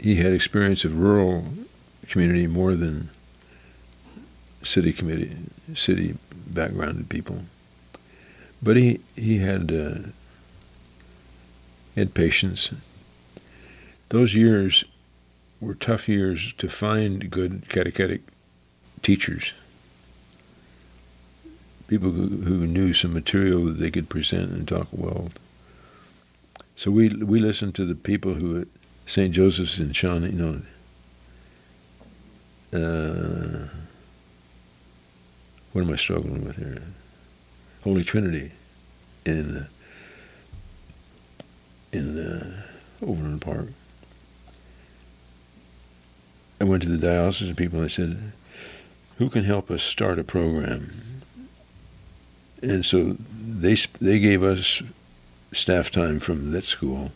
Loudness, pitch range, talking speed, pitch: -23 LUFS, 60-95 Hz, 105 wpm, 75 Hz